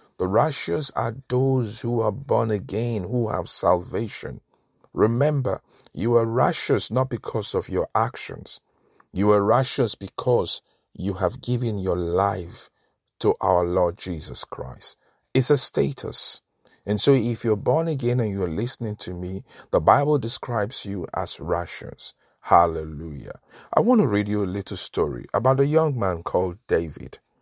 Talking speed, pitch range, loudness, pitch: 150 wpm, 95-125 Hz, -23 LUFS, 105 Hz